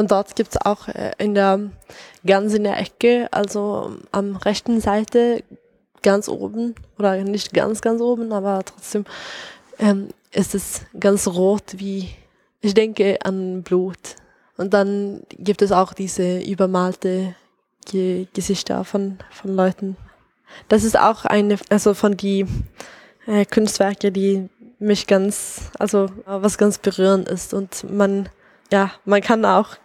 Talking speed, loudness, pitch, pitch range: 140 wpm, -20 LUFS, 200 Hz, 195-210 Hz